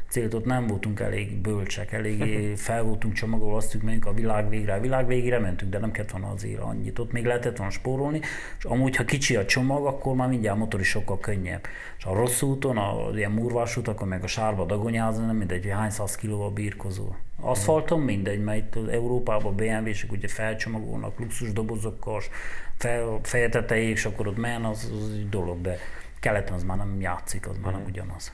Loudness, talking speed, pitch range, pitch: -27 LUFS, 200 wpm, 100-120 Hz, 110 Hz